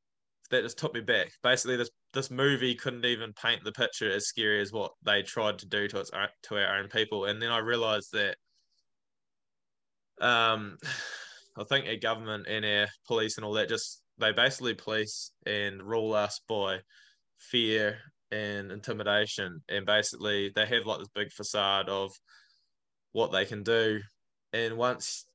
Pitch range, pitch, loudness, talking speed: 105-115 Hz, 110 Hz, -30 LUFS, 165 wpm